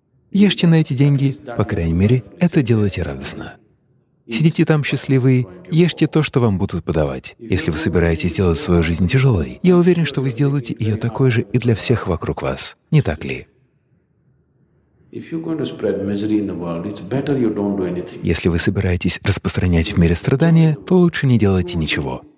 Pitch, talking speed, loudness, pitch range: 115 Hz, 145 wpm, -18 LUFS, 90-145 Hz